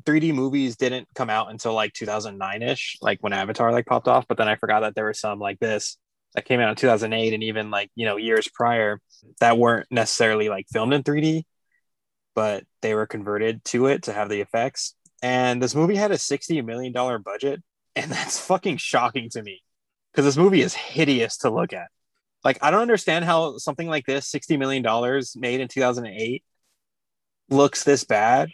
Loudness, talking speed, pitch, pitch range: -23 LUFS, 195 wpm, 125 Hz, 110-140 Hz